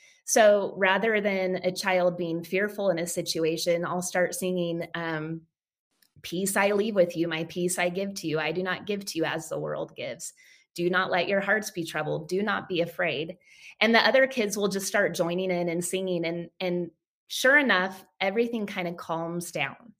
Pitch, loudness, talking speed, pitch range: 180 Hz, -26 LUFS, 200 wpm, 170-200 Hz